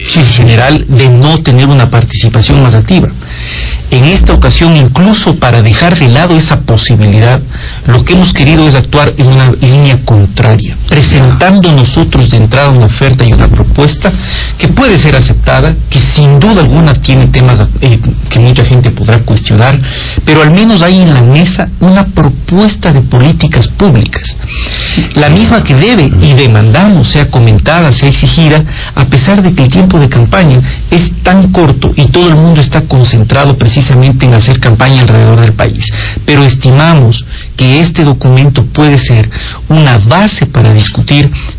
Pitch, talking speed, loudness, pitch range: 130 Hz, 160 wpm, -5 LUFS, 115-155 Hz